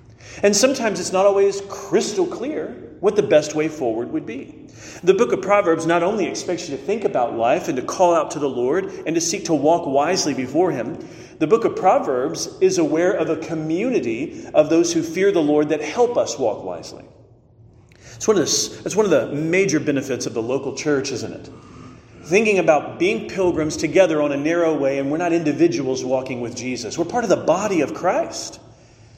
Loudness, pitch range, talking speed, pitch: -20 LUFS, 135-205 Hz, 205 wpm, 165 Hz